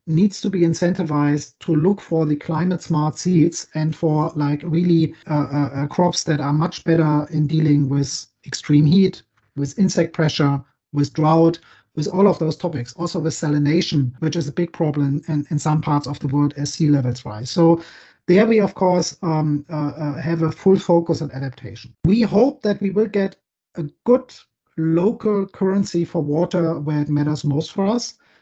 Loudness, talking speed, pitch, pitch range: -20 LUFS, 185 wpm, 160 Hz, 150-175 Hz